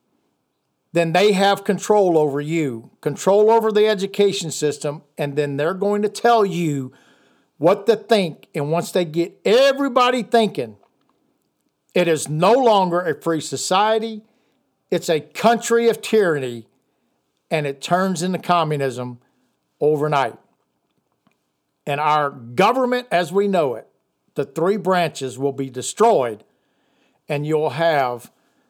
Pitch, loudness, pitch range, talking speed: 175 Hz, -19 LUFS, 145-210 Hz, 130 wpm